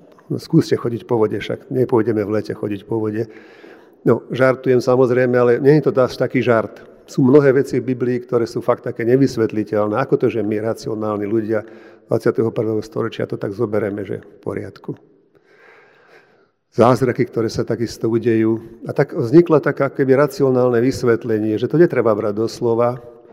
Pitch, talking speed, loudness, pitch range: 120 Hz, 165 wpm, -18 LUFS, 110-135 Hz